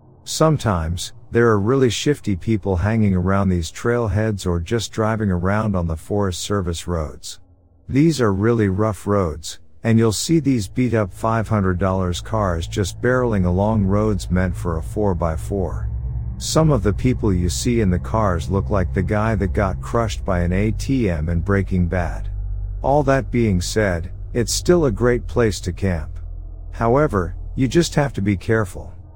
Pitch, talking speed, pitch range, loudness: 100 Hz, 165 wpm, 90-115 Hz, -20 LUFS